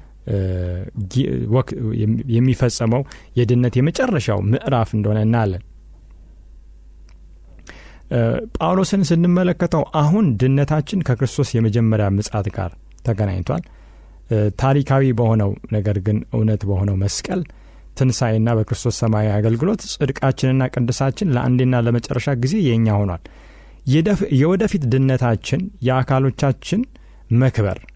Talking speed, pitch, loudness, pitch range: 80 wpm, 120 Hz, -19 LUFS, 105-135 Hz